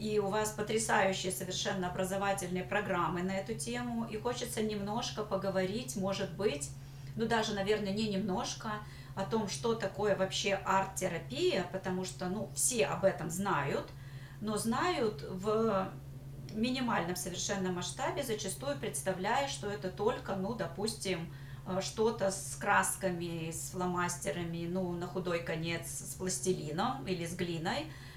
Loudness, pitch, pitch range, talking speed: -35 LUFS, 190 Hz, 170-205 Hz, 130 wpm